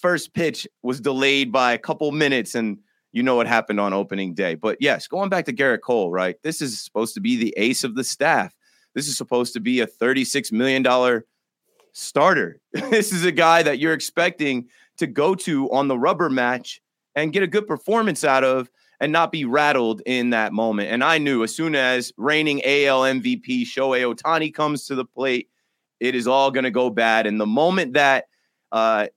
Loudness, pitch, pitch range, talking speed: -20 LUFS, 135 Hz, 120-155 Hz, 200 wpm